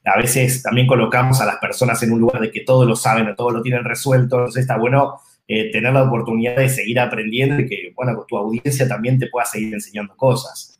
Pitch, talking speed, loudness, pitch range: 125 Hz, 230 wpm, -17 LUFS, 115-130 Hz